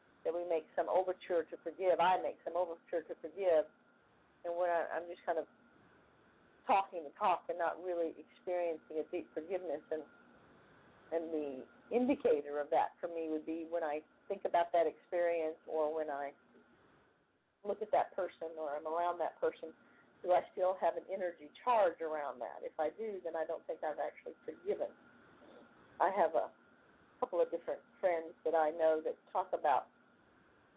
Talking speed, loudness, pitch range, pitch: 175 wpm, -37 LUFS, 160-185 Hz, 170 Hz